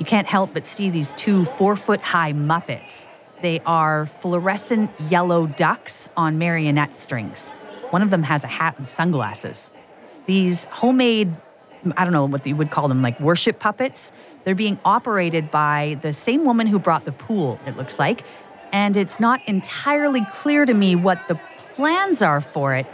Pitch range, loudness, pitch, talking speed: 155-210 Hz, -20 LUFS, 175 Hz, 175 wpm